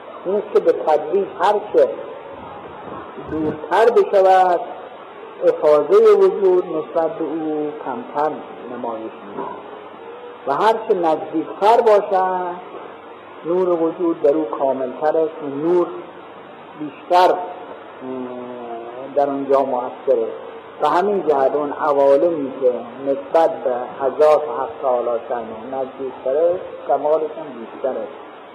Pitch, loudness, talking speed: 160 Hz, -18 LUFS, 110 wpm